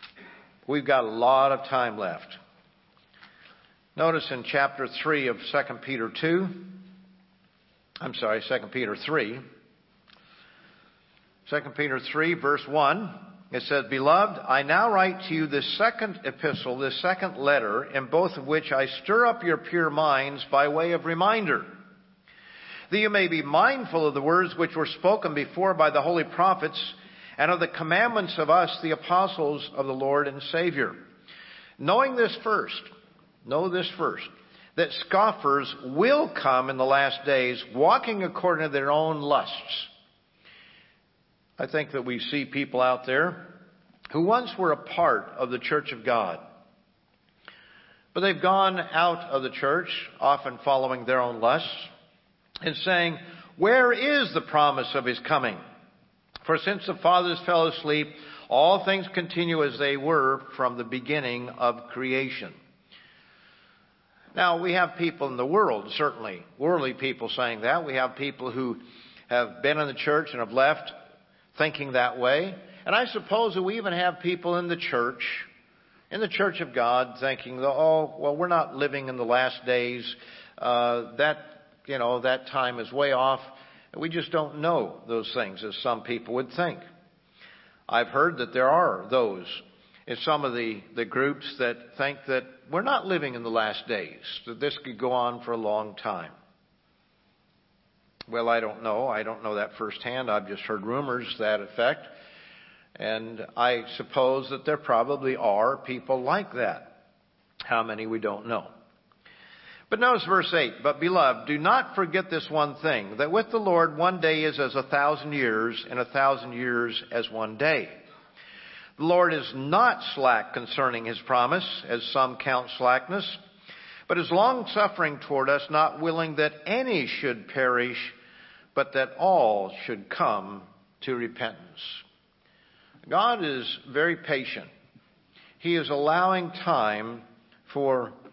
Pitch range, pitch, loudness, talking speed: 125-175 Hz, 145 Hz, -26 LUFS, 155 wpm